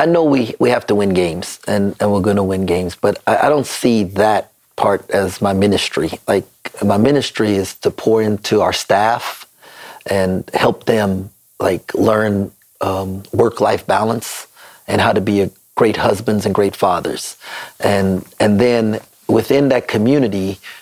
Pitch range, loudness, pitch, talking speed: 95-110 Hz, -16 LUFS, 100 Hz, 165 wpm